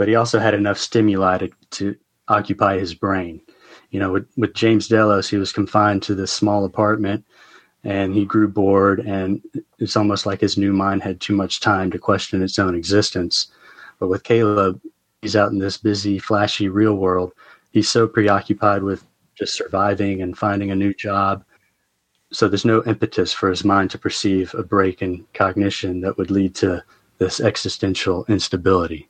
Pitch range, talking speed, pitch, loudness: 95-105 Hz, 175 wpm, 100 Hz, -19 LUFS